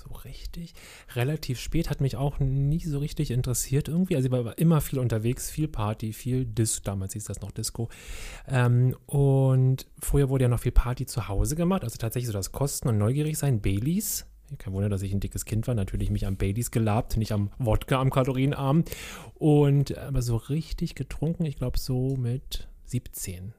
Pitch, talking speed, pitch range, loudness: 125 Hz, 190 wpm, 110-140 Hz, -27 LUFS